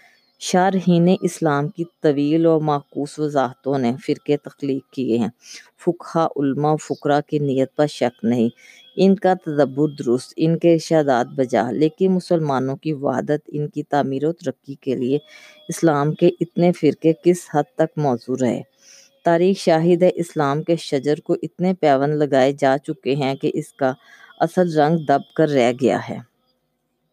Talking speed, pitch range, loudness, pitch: 155 wpm, 135-170 Hz, -20 LUFS, 150 Hz